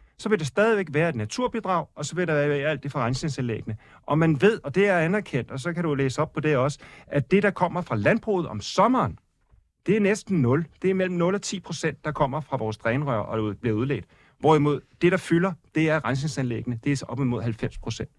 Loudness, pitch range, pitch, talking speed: -25 LUFS, 130-180 Hz, 150 Hz, 240 wpm